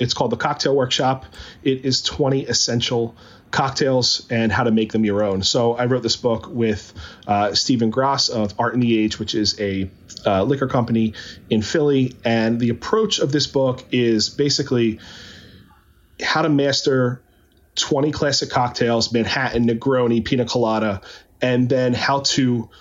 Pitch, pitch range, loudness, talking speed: 120 Hz, 110-130 Hz, -19 LUFS, 160 wpm